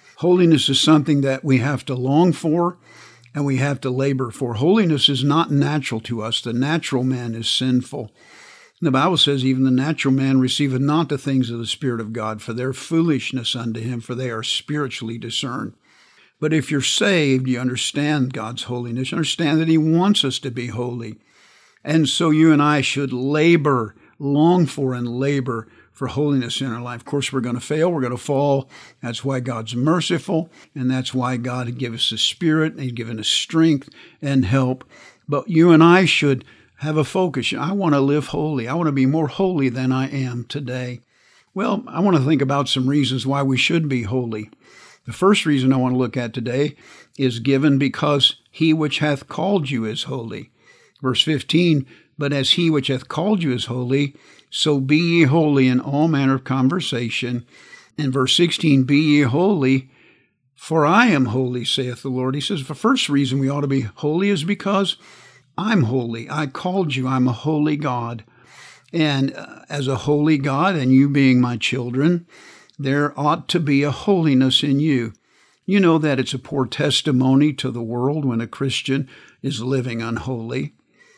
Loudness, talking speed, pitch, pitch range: -19 LUFS, 190 wpm, 135 Hz, 125-155 Hz